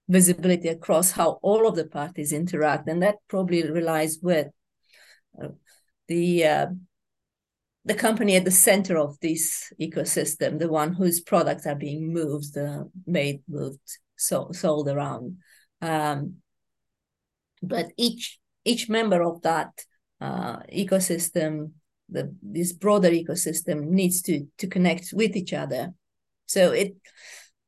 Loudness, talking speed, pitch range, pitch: -24 LUFS, 130 wpm, 155-190 Hz, 170 Hz